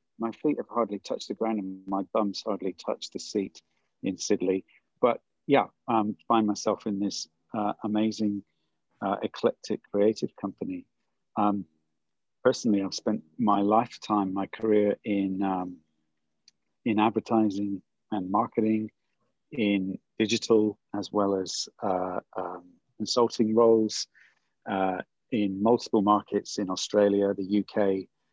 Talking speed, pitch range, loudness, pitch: 130 wpm, 95-110 Hz, -28 LUFS, 105 Hz